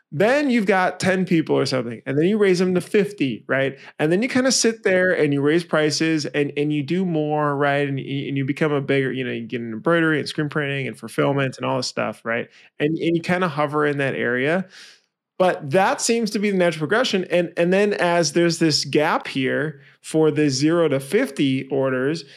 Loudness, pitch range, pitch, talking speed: -21 LUFS, 140-180 Hz, 155 Hz, 230 wpm